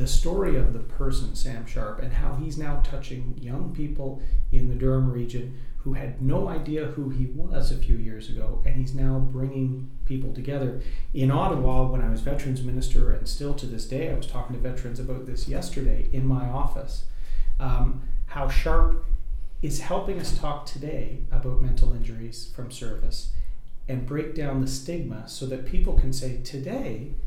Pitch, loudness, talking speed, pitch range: 130 Hz, -30 LUFS, 180 wpm, 125-140 Hz